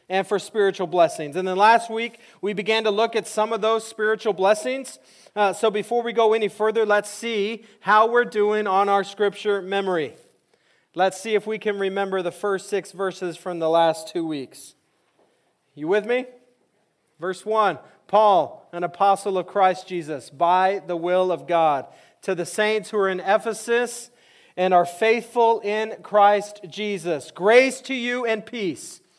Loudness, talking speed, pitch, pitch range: -22 LUFS, 170 wpm, 205 Hz, 185-220 Hz